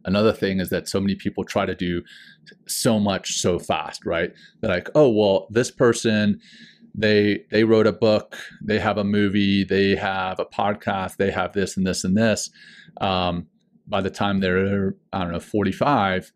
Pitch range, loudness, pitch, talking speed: 95-105 Hz, -22 LUFS, 100 Hz, 185 wpm